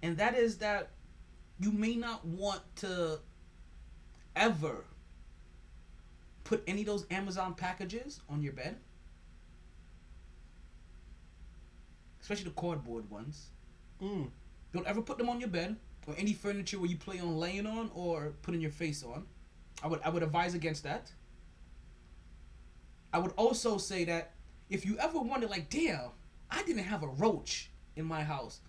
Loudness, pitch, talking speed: -36 LUFS, 160 Hz, 150 wpm